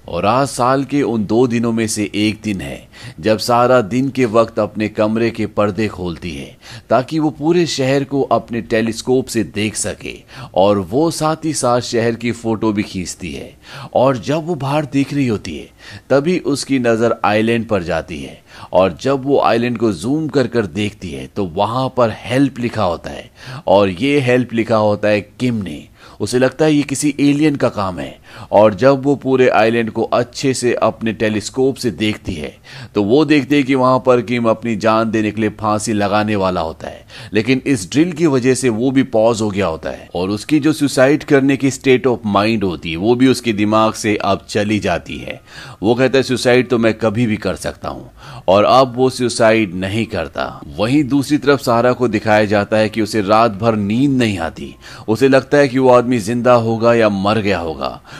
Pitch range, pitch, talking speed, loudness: 105-130 Hz, 115 Hz, 145 wpm, -15 LUFS